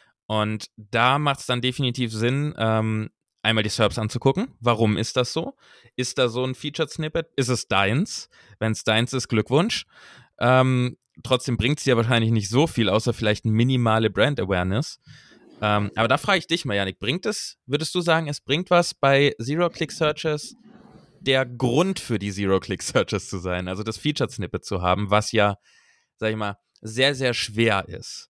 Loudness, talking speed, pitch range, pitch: -23 LUFS, 180 wpm, 110-145 Hz, 120 Hz